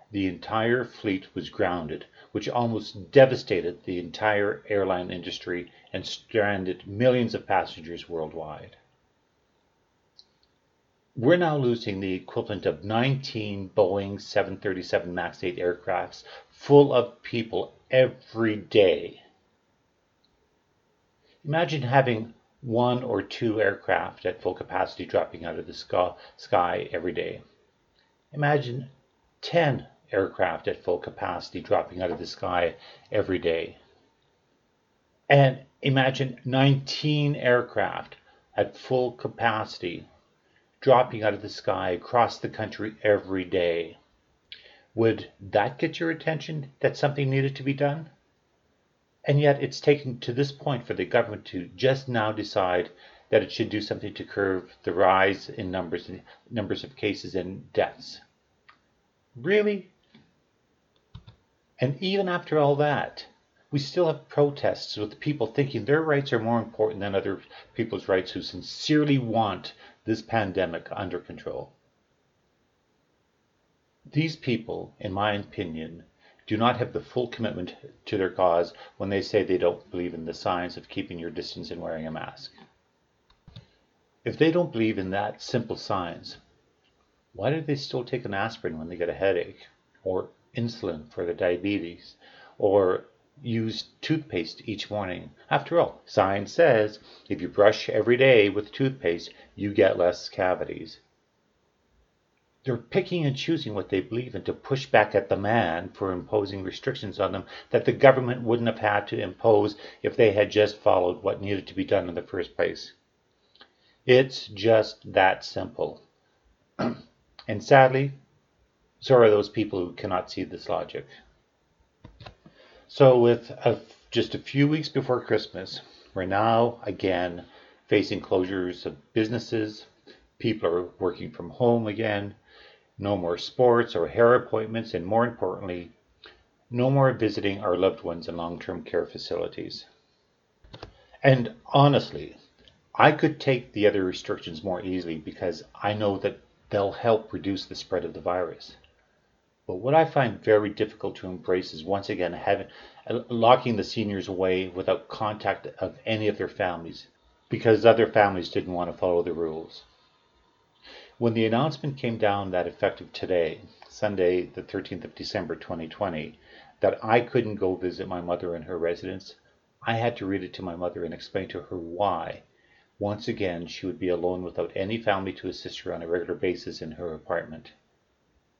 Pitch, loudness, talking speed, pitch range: 110 Hz, -26 LUFS, 145 wpm, 95-130 Hz